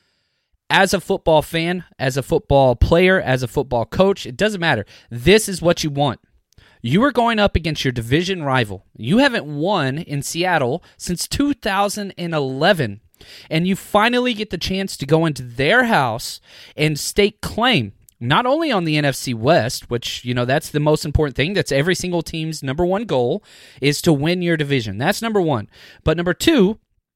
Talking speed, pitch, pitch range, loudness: 180 wpm, 160 Hz, 135-190 Hz, -18 LUFS